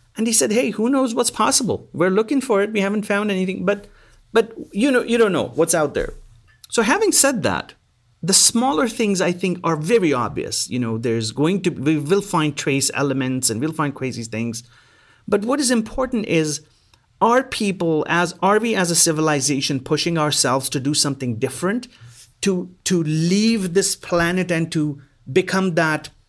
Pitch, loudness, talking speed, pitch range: 175 Hz, -19 LUFS, 185 wpm, 145-215 Hz